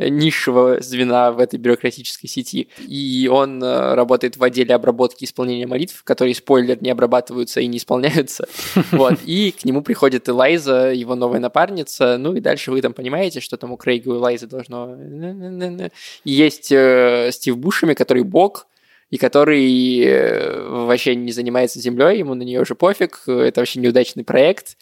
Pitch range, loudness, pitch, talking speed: 125-140 Hz, -17 LUFS, 125 Hz, 155 wpm